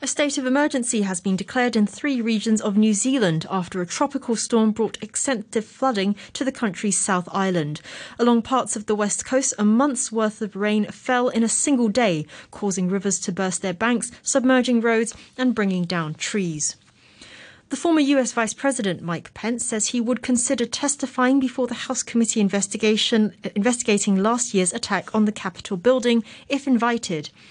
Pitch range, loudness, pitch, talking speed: 200-250 Hz, -22 LUFS, 225 Hz, 175 wpm